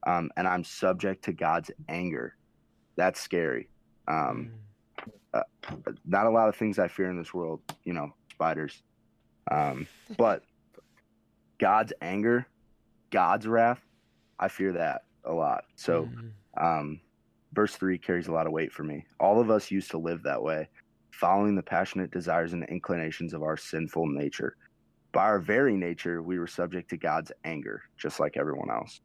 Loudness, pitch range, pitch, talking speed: -30 LUFS, 85-105 Hz, 90 Hz, 160 wpm